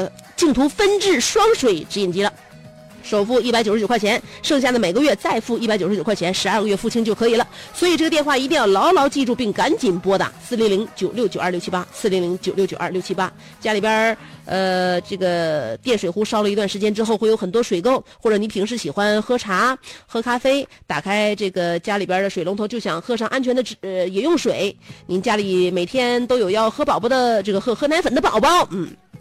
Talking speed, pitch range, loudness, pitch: 335 characters per minute, 190-245 Hz, -19 LUFS, 215 Hz